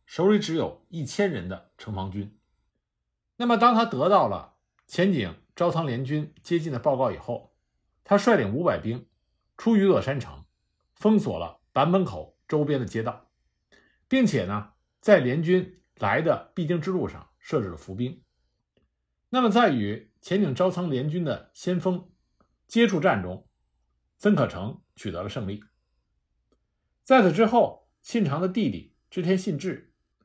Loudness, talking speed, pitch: -25 LUFS, 215 characters per minute, 165 Hz